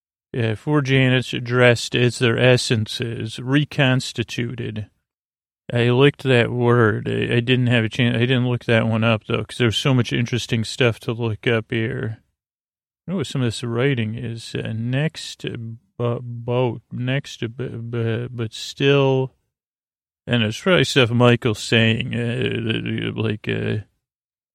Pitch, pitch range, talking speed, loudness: 120 Hz, 115-130 Hz, 145 wpm, -20 LUFS